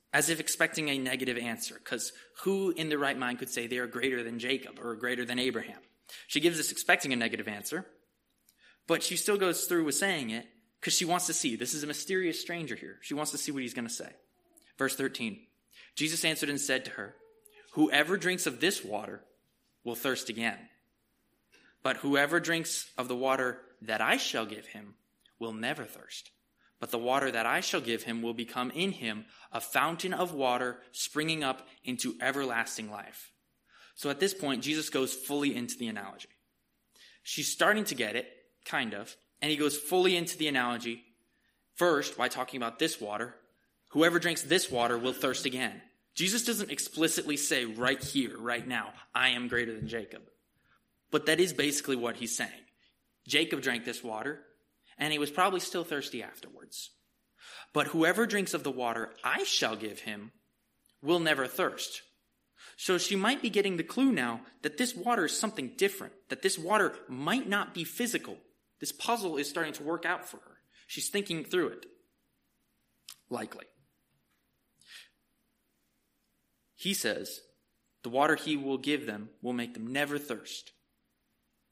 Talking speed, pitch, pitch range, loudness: 175 wpm, 145 Hz, 125-175 Hz, -31 LUFS